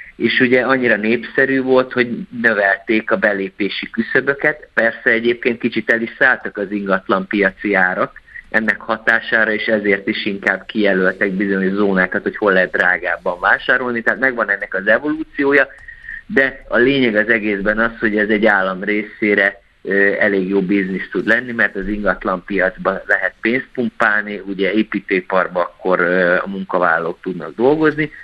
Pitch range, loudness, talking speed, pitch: 100-120 Hz, -16 LUFS, 145 wpm, 105 Hz